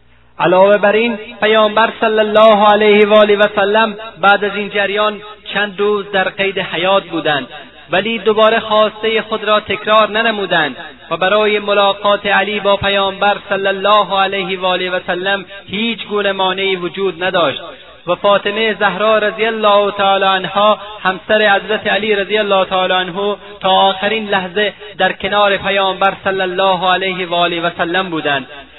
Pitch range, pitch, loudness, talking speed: 190-210 Hz, 200 Hz, -13 LUFS, 150 wpm